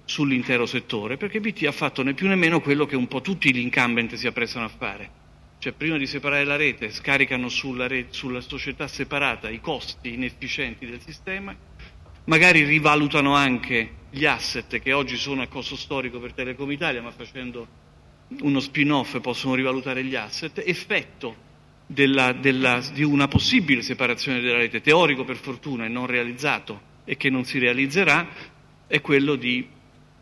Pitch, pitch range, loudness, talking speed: 130 Hz, 125-145 Hz, -22 LUFS, 165 wpm